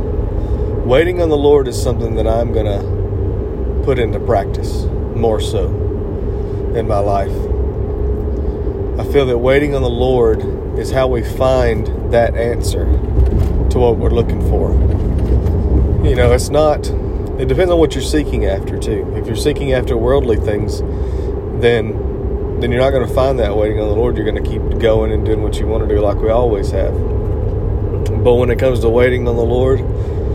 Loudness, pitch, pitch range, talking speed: -16 LUFS, 105 Hz, 100-120 Hz, 180 wpm